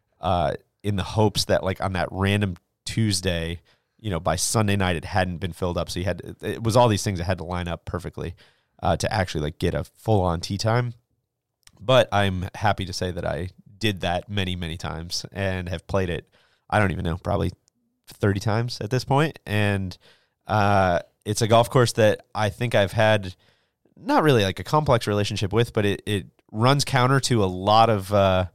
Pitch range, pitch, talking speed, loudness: 90-110 Hz, 100 Hz, 210 wpm, -23 LUFS